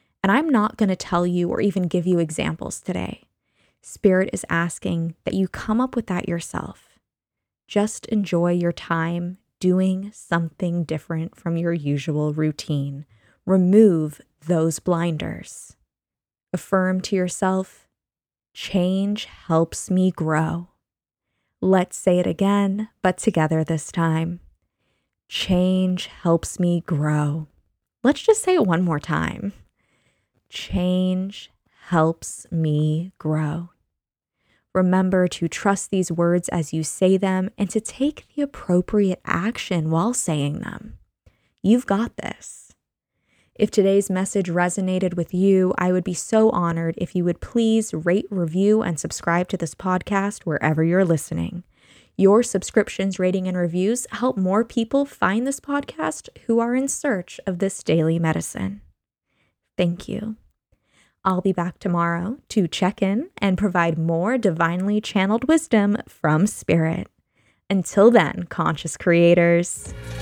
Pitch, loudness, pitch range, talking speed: 185 Hz, -22 LUFS, 165-200 Hz, 130 wpm